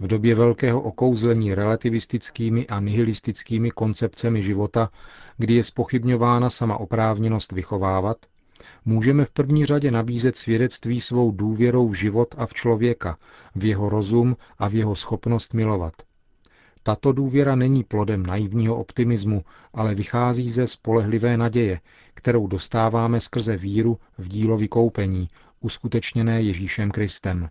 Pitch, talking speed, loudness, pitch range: 115 Hz, 125 wpm, -22 LUFS, 105-120 Hz